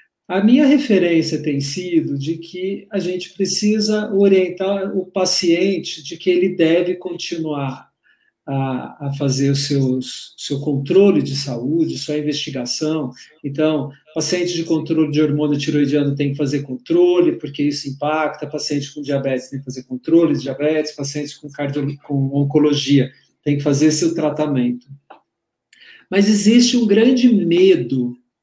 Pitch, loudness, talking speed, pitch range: 155 Hz, -18 LUFS, 140 wpm, 140-185 Hz